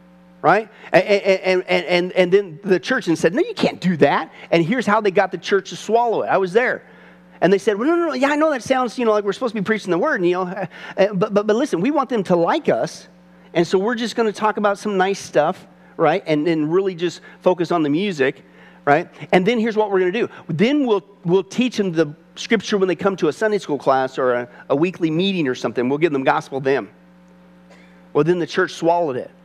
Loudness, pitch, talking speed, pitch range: -19 LUFS, 185 Hz, 255 wpm, 160-210 Hz